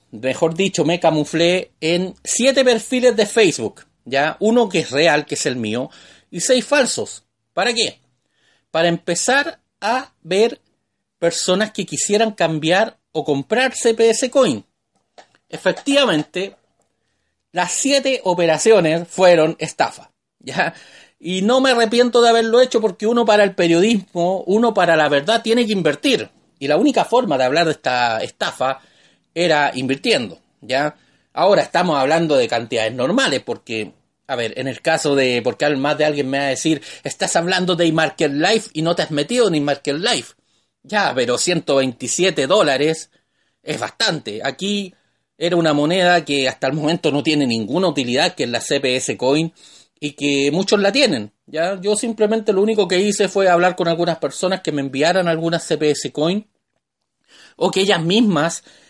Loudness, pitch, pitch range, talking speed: -17 LUFS, 175 Hz, 150-215 Hz, 160 wpm